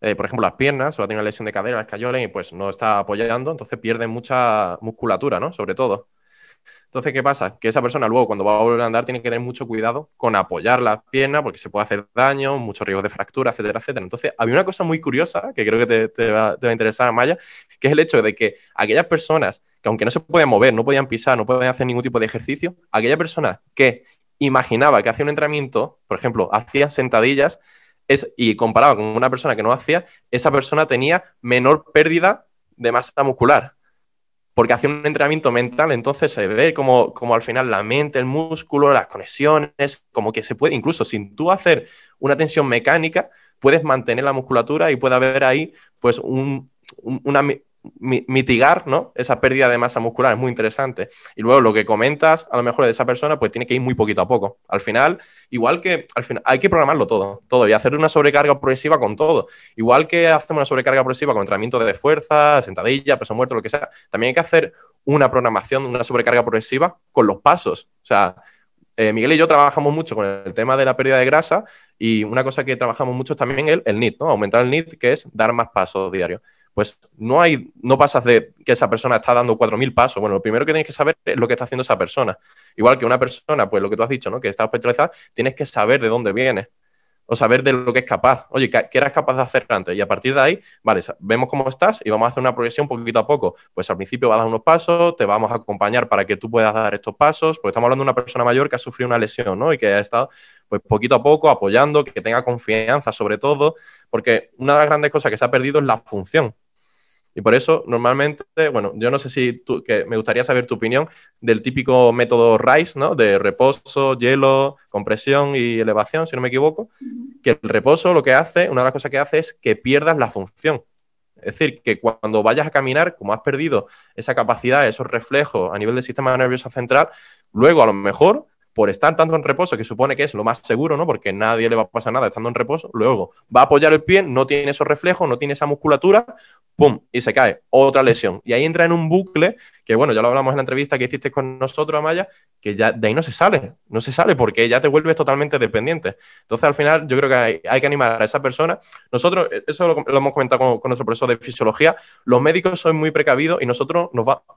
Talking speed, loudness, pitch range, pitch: 235 wpm, -17 LUFS, 115-150 Hz, 130 Hz